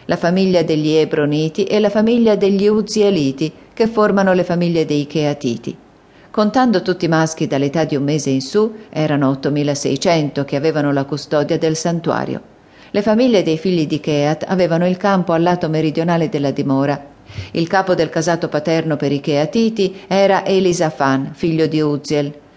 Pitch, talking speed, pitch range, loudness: 160 Hz, 160 wpm, 145-190 Hz, -16 LUFS